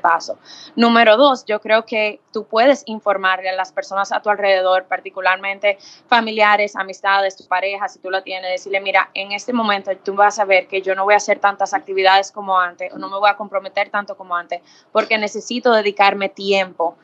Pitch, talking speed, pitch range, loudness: 200 Hz, 195 wpm, 190-210 Hz, -17 LUFS